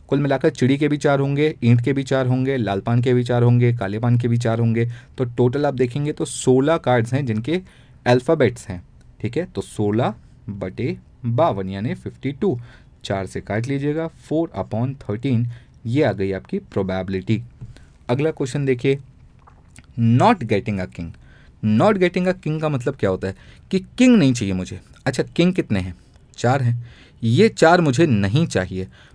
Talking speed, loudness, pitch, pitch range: 165 wpm, -20 LUFS, 125 Hz, 110-145 Hz